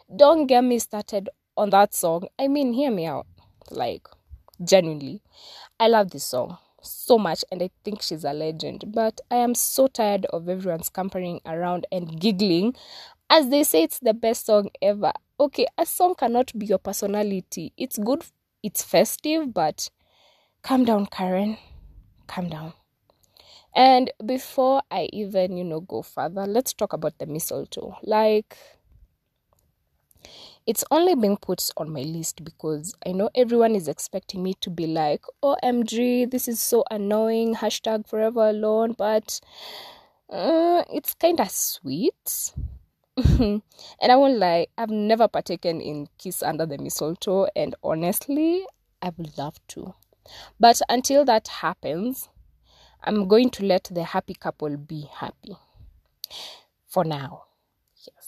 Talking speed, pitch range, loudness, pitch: 145 wpm, 180-245 Hz, -23 LUFS, 210 Hz